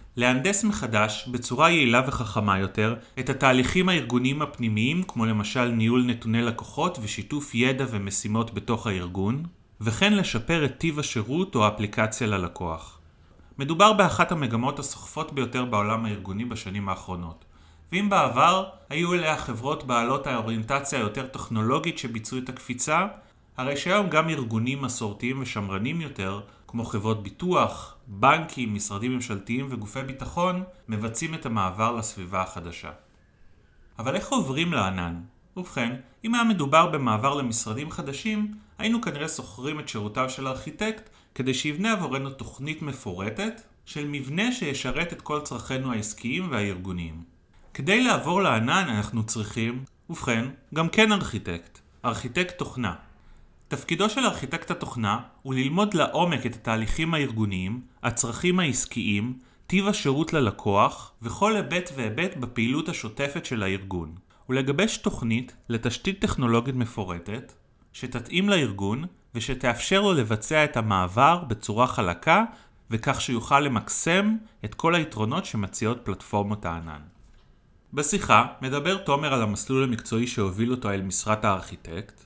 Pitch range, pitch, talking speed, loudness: 110-155 Hz, 125 Hz, 120 wpm, -25 LUFS